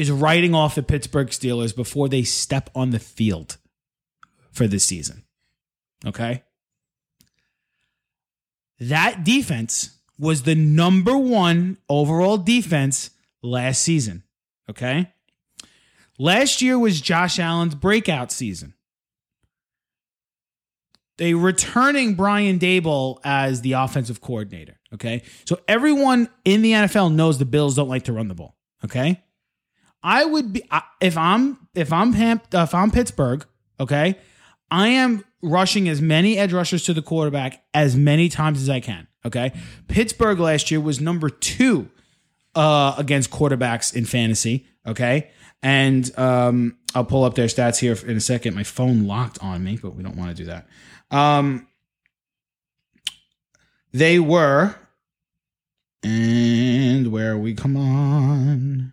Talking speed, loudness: 130 wpm, -19 LUFS